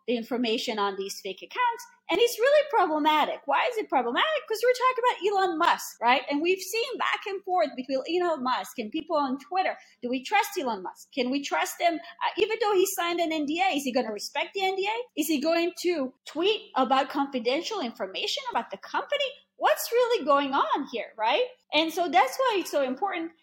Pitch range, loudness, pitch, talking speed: 275-415 Hz, -27 LUFS, 340 Hz, 205 wpm